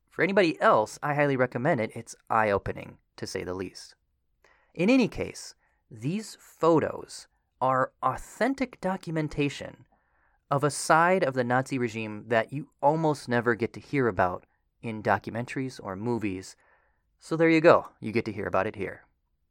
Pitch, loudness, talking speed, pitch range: 125 Hz, -27 LUFS, 160 wpm, 110-155 Hz